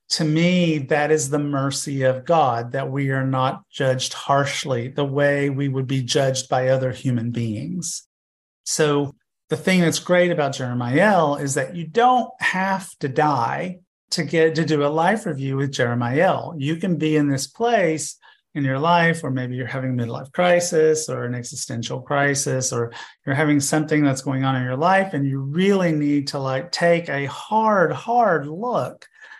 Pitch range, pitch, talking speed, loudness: 130-165 Hz, 145 Hz, 185 wpm, -21 LUFS